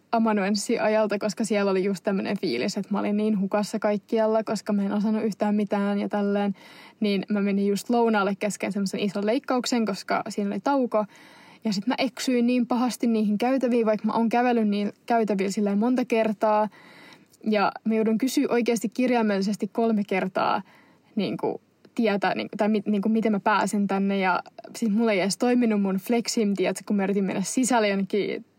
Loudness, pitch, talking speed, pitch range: -25 LUFS, 215 Hz, 185 wpm, 205-230 Hz